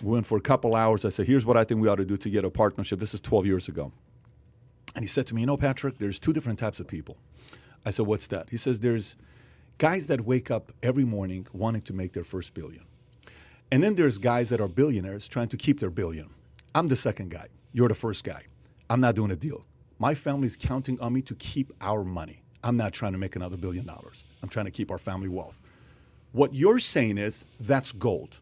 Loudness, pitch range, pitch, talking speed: -27 LUFS, 100-125 Hz, 115 Hz, 240 wpm